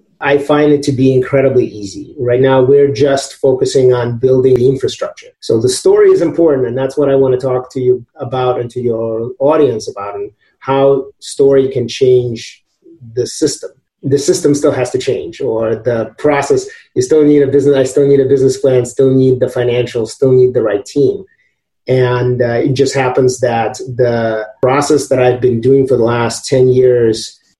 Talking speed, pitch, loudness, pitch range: 195 wpm, 135 Hz, -12 LUFS, 125-145 Hz